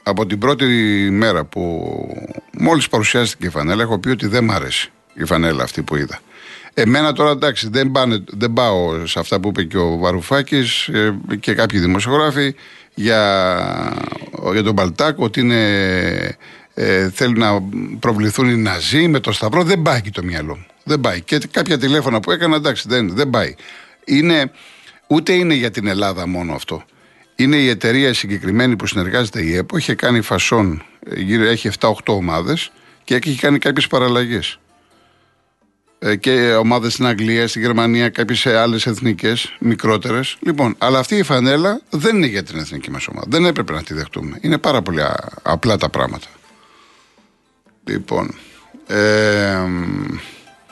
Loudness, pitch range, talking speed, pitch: -16 LUFS, 100-130 Hz, 155 wpm, 115 Hz